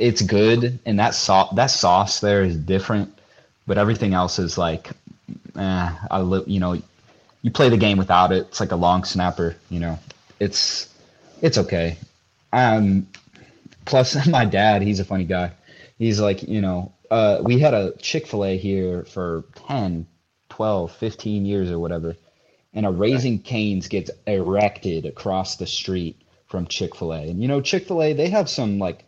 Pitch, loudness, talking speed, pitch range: 100 Hz, -21 LUFS, 175 wpm, 90-110 Hz